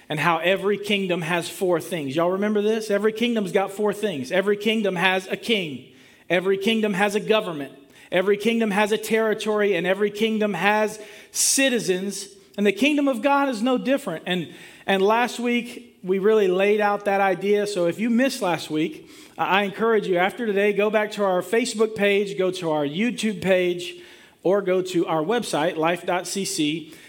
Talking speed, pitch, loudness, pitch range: 180 wpm, 200 Hz, -22 LUFS, 180-220 Hz